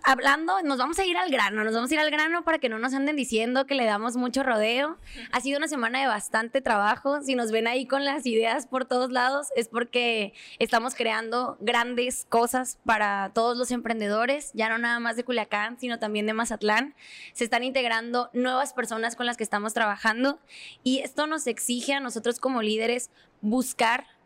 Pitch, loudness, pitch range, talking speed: 245 Hz, -26 LUFS, 225-265 Hz, 200 wpm